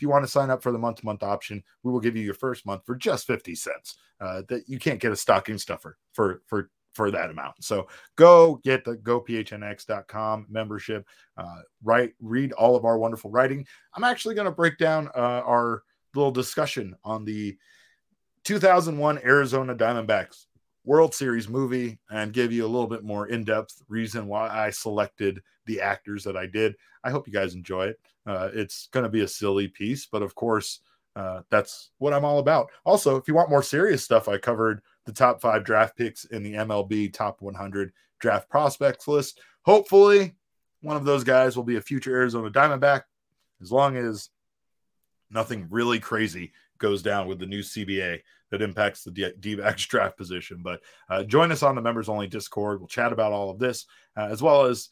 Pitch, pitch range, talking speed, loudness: 115 Hz, 105-135 Hz, 190 wpm, -24 LUFS